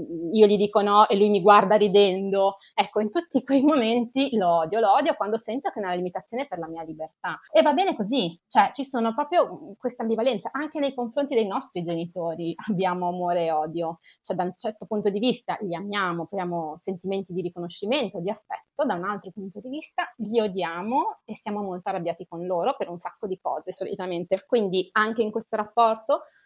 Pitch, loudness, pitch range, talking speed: 210 Hz, -25 LUFS, 180-245 Hz, 200 wpm